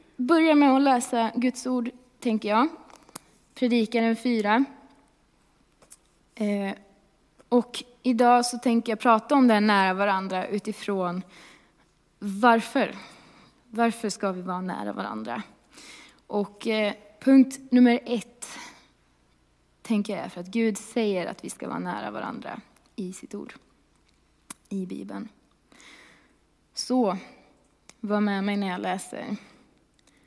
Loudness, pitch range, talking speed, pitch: -25 LUFS, 205-250 Hz, 115 wpm, 225 Hz